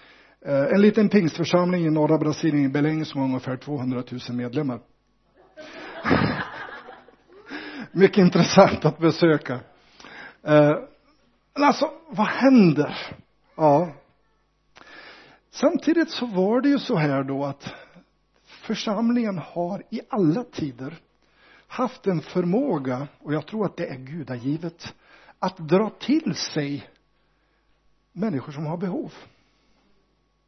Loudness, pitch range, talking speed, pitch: -23 LUFS, 145-215 Hz, 110 wpm, 170 Hz